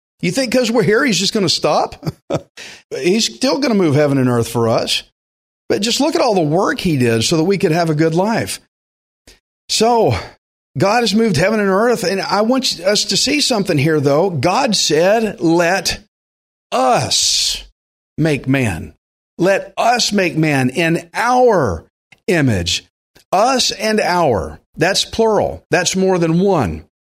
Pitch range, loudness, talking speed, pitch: 135-225 Hz, -15 LUFS, 165 wpm, 180 Hz